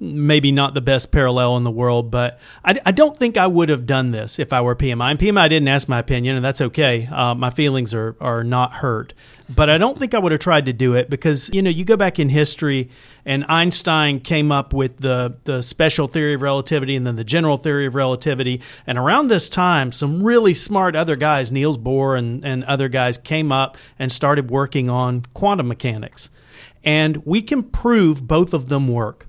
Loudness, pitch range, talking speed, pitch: -18 LUFS, 125-155 Hz, 215 wpm, 140 Hz